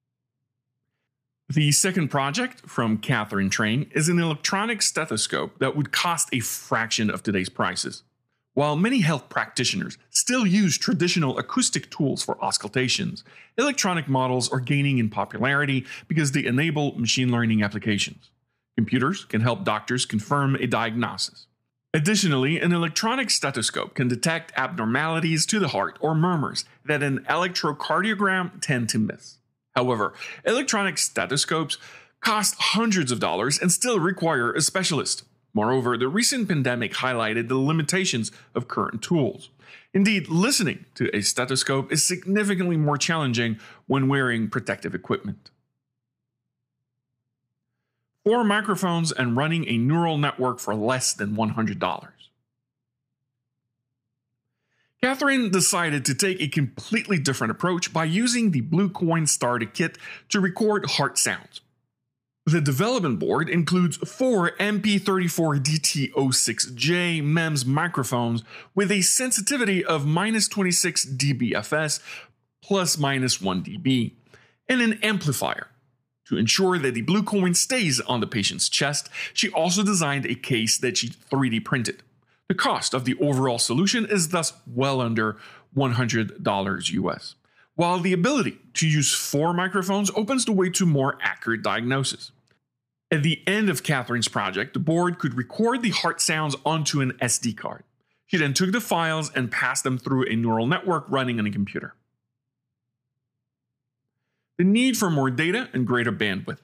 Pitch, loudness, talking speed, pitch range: 140 Hz, -23 LUFS, 135 wpm, 125-180 Hz